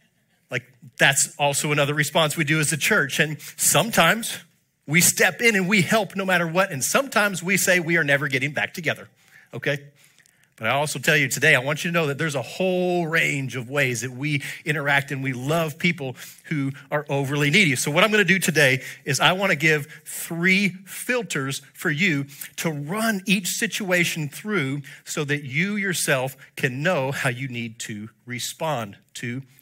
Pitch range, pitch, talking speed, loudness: 140-180 Hz, 150 Hz, 185 wpm, -21 LUFS